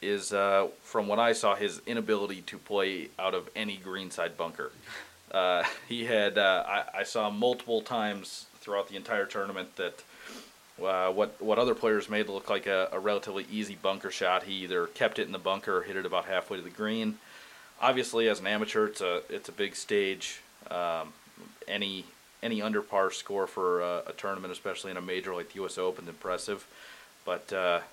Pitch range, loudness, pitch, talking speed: 95-115 Hz, -31 LUFS, 105 Hz, 195 wpm